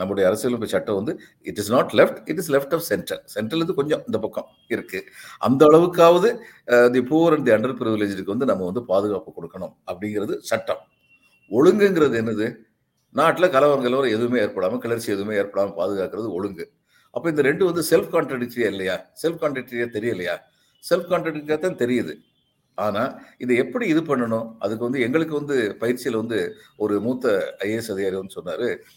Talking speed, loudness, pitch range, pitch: 140 wpm, -22 LUFS, 115-165 Hz, 130 Hz